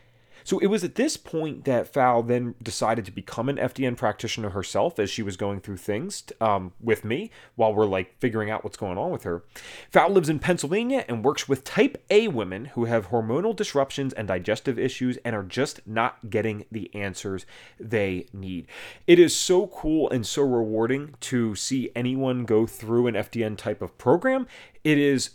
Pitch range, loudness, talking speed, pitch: 110-140 Hz, -25 LUFS, 190 wpm, 120 Hz